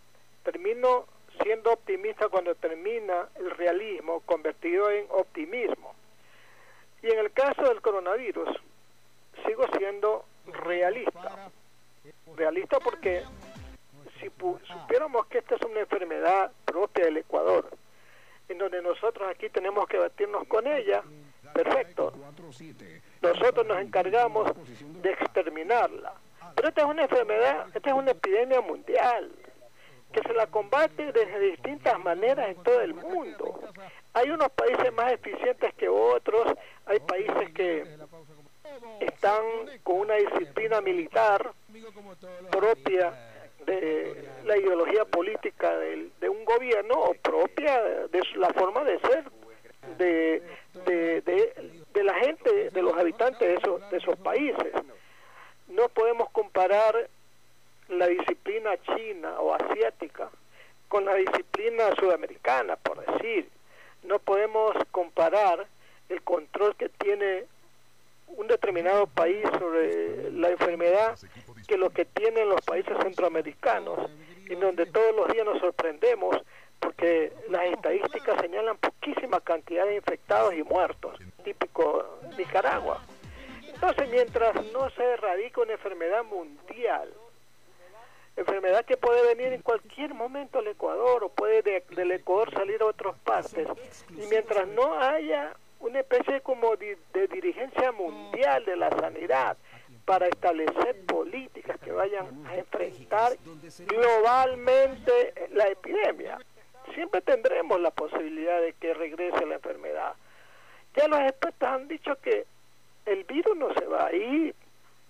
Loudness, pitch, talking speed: -27 LUFS, 255 Hz, 125 wpm